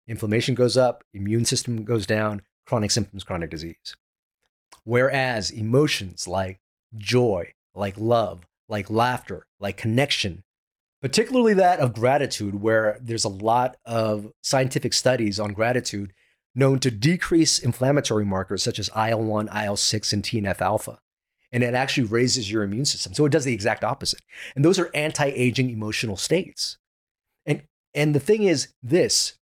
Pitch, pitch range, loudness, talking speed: 115 Hz, 105-130 Hz, -23 LUFS, 145 wpm